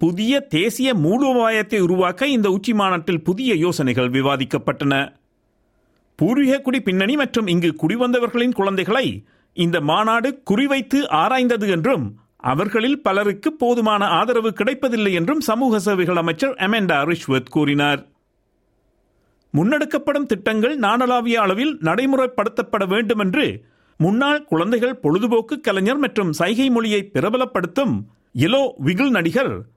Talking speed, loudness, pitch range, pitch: 105 wpm, -19 LUFS, 170-255 Hz, 215 Hz